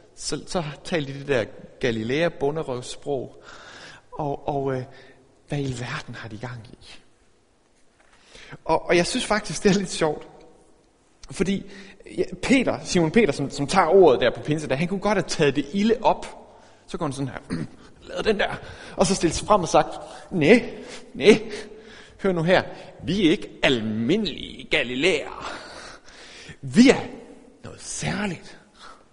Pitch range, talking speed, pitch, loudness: 140-200 Hz, 160 wpm, 160 Hz, -23 LUFS